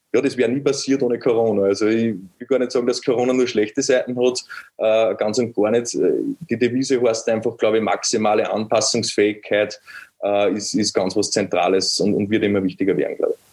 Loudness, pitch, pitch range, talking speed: -19 LUFS, 115 Hz, 105-125 Hz, 205 wpm